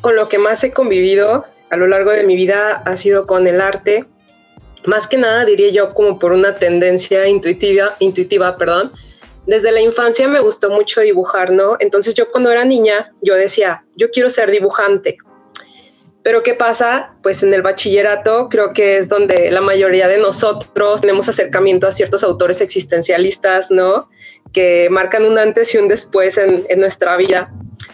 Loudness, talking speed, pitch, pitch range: -13 LUFS, 175 wpm, 200 Hz, 190-220 Hz